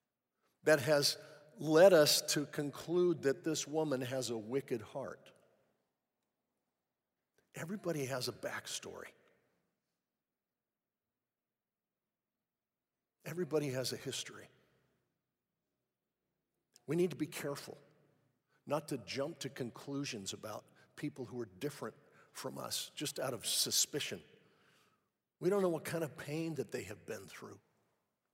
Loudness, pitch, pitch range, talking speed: -36 LUFS, 145 Hz, 130-155 Hz, 115 wpm